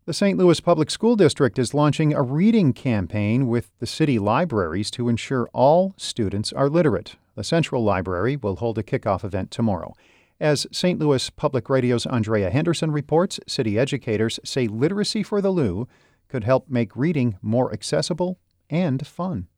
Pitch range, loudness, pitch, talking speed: 110-160 Hz, -22 LUFS, 130 Hz, 160 wpm